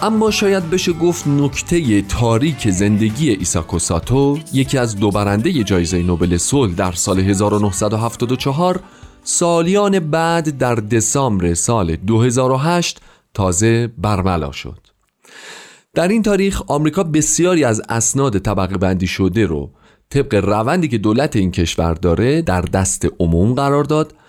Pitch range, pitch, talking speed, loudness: 95-155 Hz, 115 Hz, 125 wpm, -16 LUFS